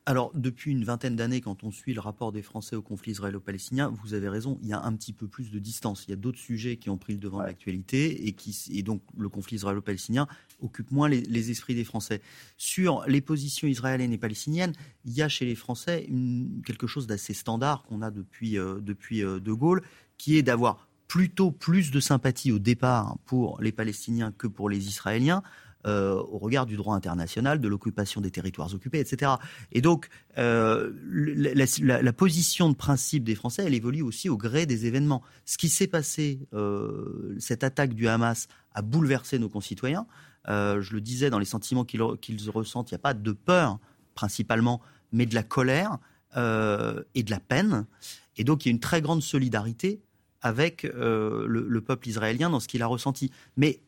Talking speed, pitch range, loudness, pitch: 205 wpm, 105-140 Hz, -28 LUFS, 120 Hz